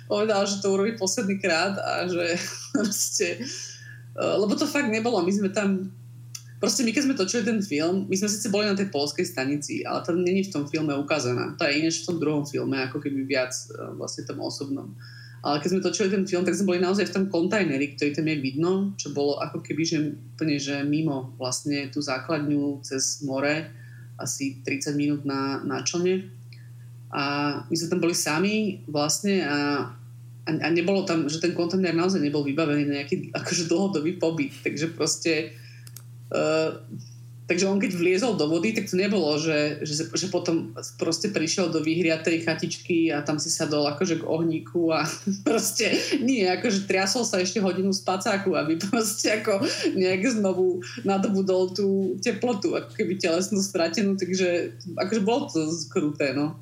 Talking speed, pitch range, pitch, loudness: 175 wpm, 145-190 Hz, 165 Hz, -25 LUFS